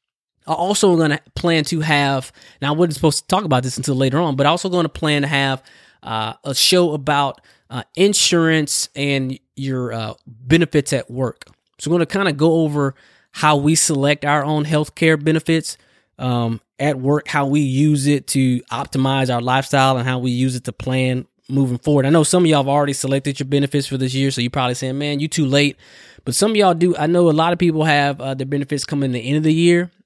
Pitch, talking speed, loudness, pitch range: 145 Hz, 235 wpm, -18 LUFS, 135-160 Hz